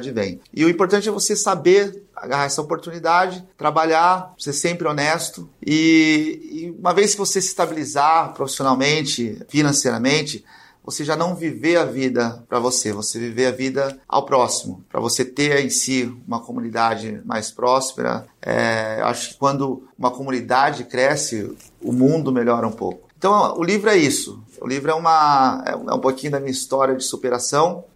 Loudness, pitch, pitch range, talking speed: -19 LUFS, 140 Hz, 125-170 Hz, 170 wpm